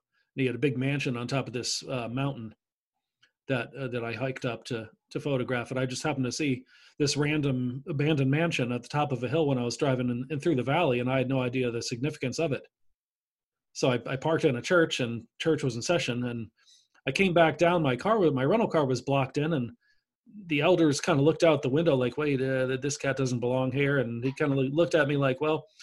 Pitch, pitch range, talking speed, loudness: 135 Hz, 125-155 Hz, 245 wpm, -28 LUFS